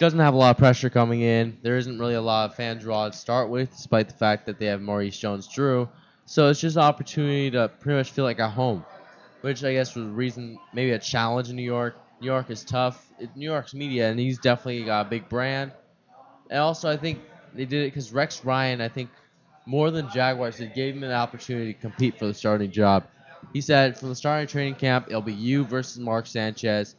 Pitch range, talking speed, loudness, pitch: 115-140 Hz, 235 wpm, -25 LUFS, 125 Hz